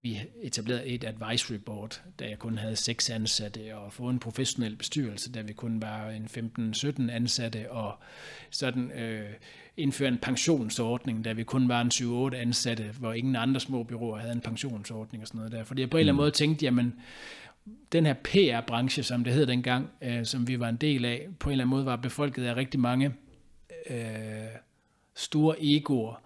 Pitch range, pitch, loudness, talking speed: 115-130 Hz, 120 Hz, -30 LUFS, 190 wpm